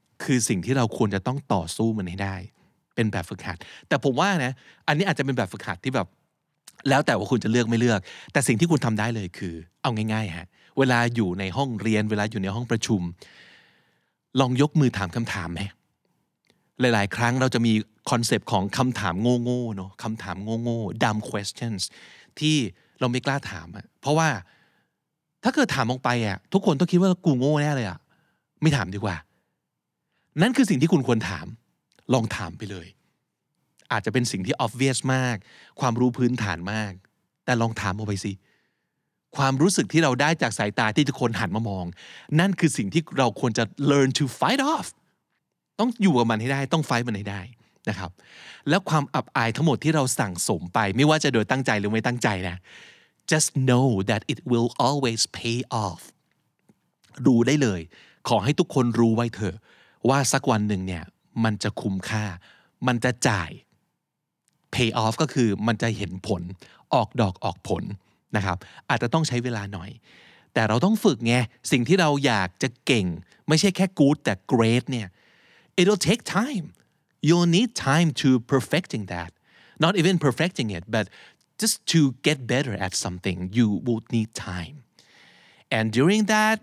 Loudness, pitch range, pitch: -24 LUFS, 105-145 Hz, 120 Hz